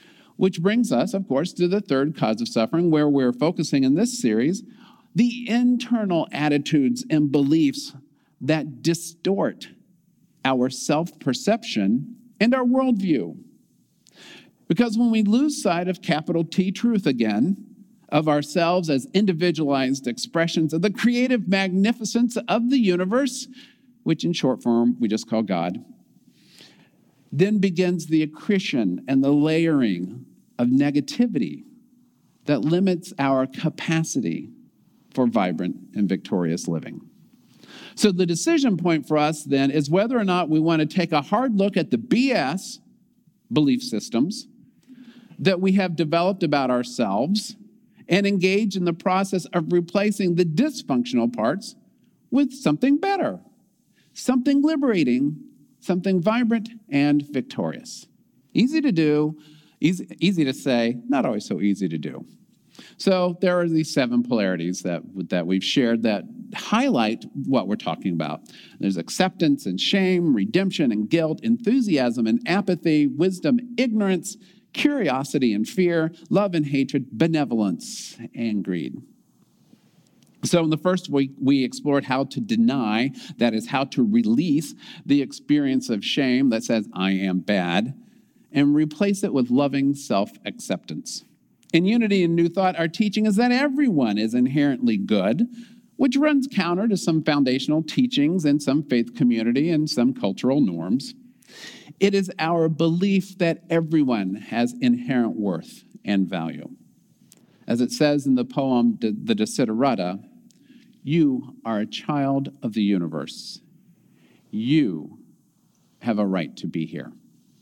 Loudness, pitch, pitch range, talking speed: -22 LUFS, 175 Hz, 140-230 Hz, 135 wpm